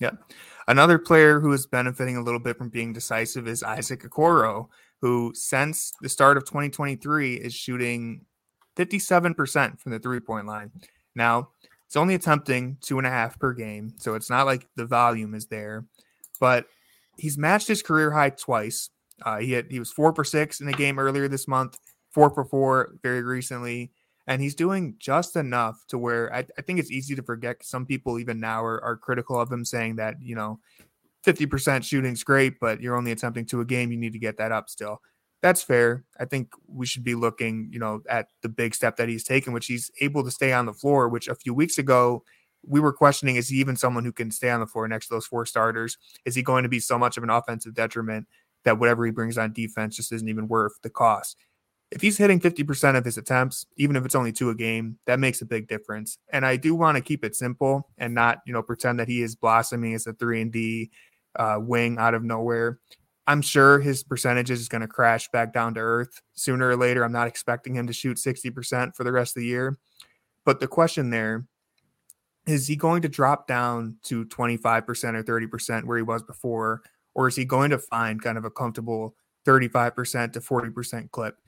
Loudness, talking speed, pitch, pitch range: -24 LUFS, 215 wpm, 125 Hz, 115-135 Hz